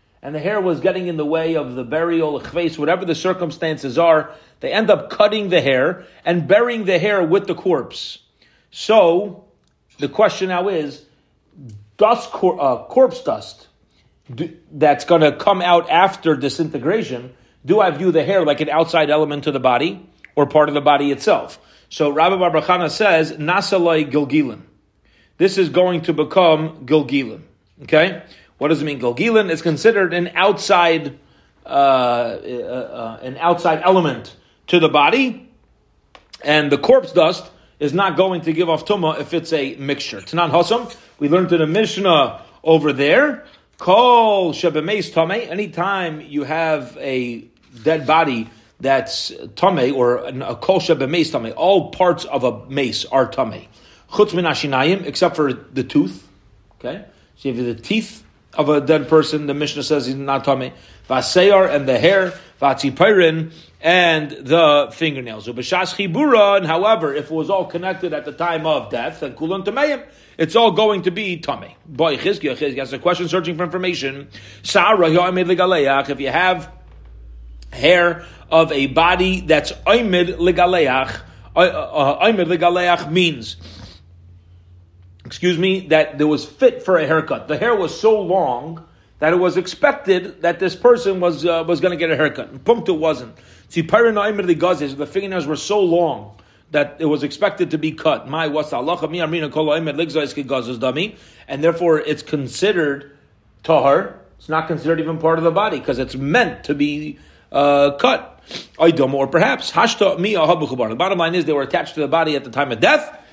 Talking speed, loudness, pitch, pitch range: 155 wpm, -17 LUFS, 160 Hz, 140-180 Hz